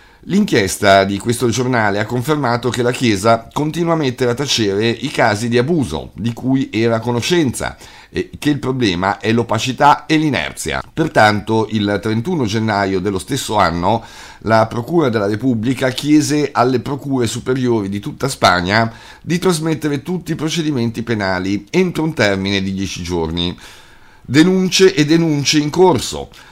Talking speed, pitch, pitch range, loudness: 145 wpm, 120 Hz, 105-150 Hz, -16 LUFS